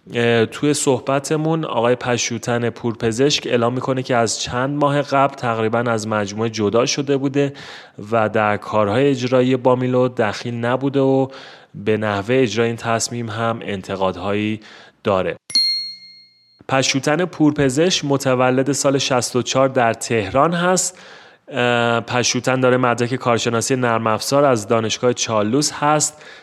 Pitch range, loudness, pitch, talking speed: 115-135 Hz, -18 LUFS, 125 Hz, 115 wpm